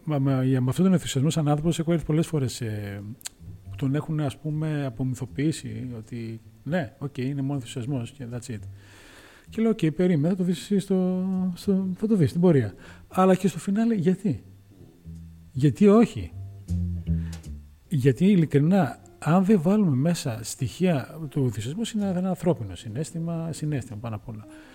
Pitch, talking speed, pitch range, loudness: 140 Hz, 155 wpm, 115-180 Hz, -25 LUFS